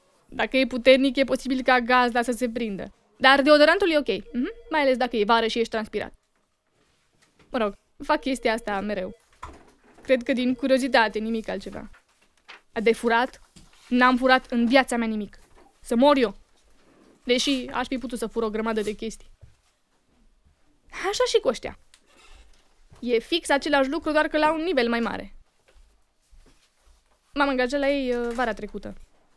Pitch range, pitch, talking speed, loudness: 230-275 Hz, 250 Hz, 160 wpm, -23 LUFS